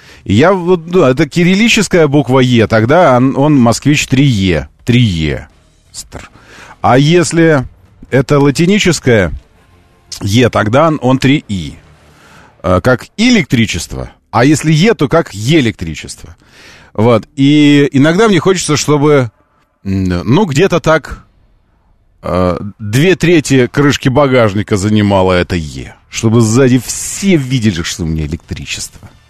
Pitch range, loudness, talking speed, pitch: 95-150 Hz, -10 LUFS, 115 wpm, 125 Hz